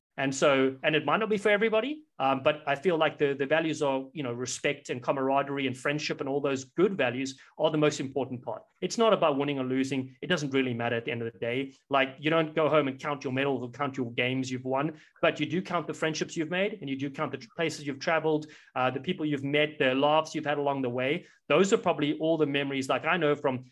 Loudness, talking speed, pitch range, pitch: -28 LUFS, 265 wpm, 135-160 Hz, 145 Hz